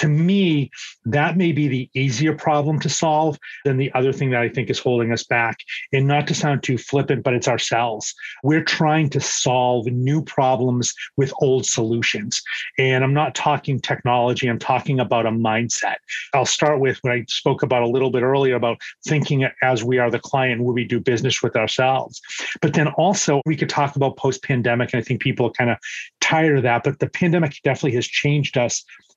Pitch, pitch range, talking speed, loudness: 130 Hz, 125-145 Hz, 205 wpm, -20 LUFS